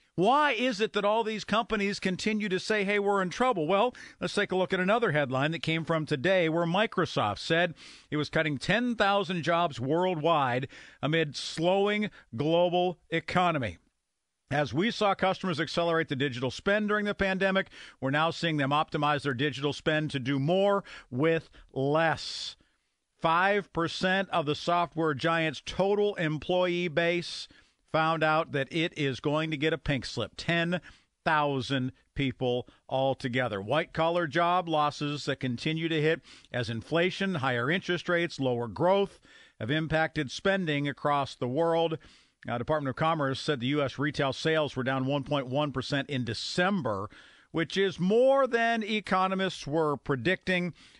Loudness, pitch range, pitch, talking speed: -28 LUFS, 145-185 Hz, 165 Hz, 150 wpm